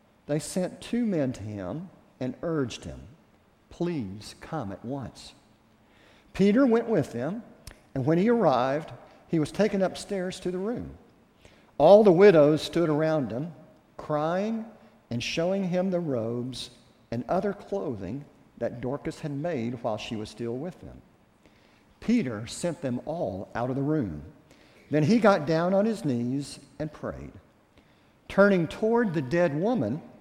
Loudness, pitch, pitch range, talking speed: -27 LUFS, 155 Hz, 125-195 Hz, 150 wpm